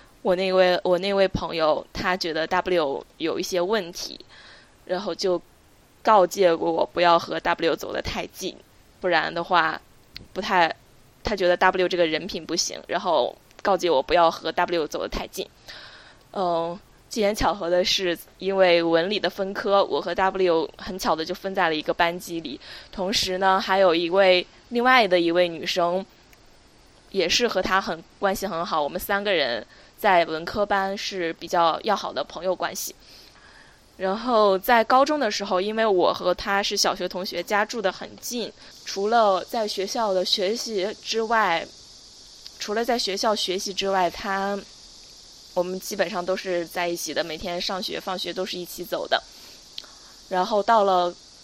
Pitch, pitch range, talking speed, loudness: 185 Hz, 175-200 Hz, 235 characters per minute, -23 LUFS